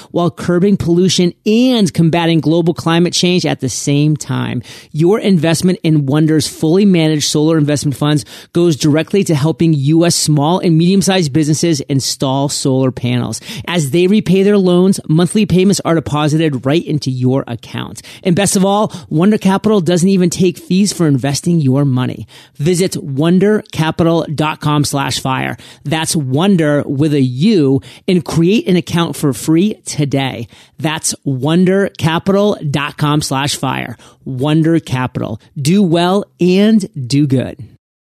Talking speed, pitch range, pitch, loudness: 140 wpm, 145-180 Hz, 160 Hz, -13 LUFS